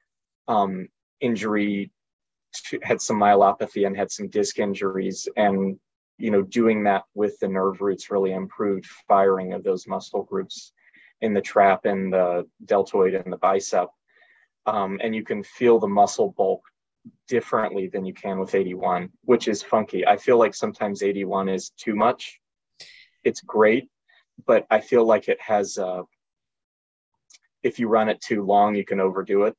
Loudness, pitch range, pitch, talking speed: -23 LUFS, 95-105 Hz, 100 Hz, 160 wpm